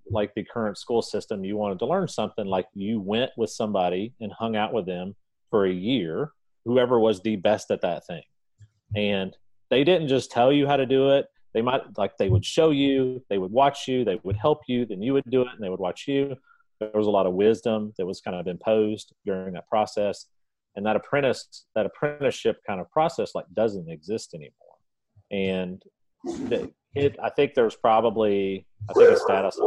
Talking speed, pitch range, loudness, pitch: 205 wpm, 100-135 Hz, -25 LUFS, 110 Hz